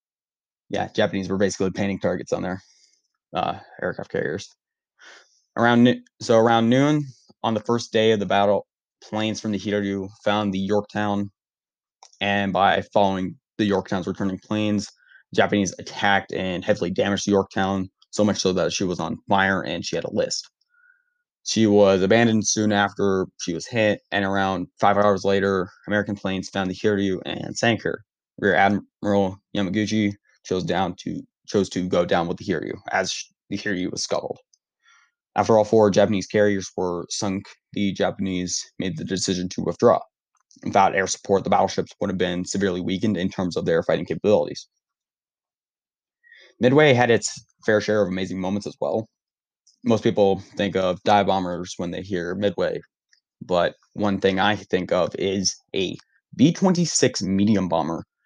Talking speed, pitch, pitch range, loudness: 165 wpm, 100 Hz, 95-105 Hz, -22 LUFS